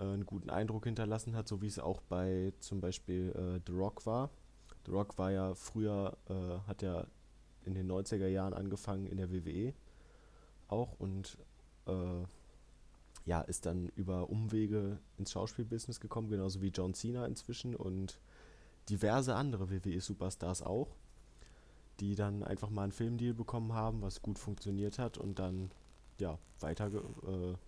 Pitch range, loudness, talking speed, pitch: 95-110 Hz, -40 LUFS, 155 wpm, 95 Hz